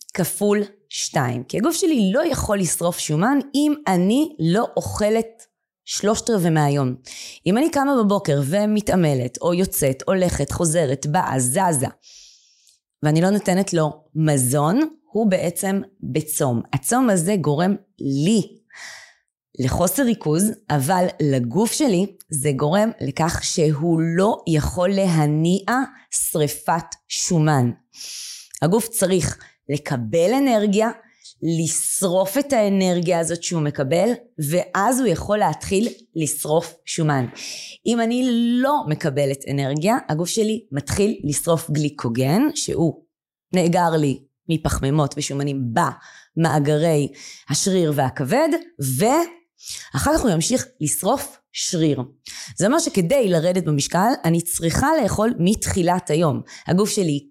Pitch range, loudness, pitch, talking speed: 150-210 Hz, -20 LUFS, 175 Hz, 110 wpm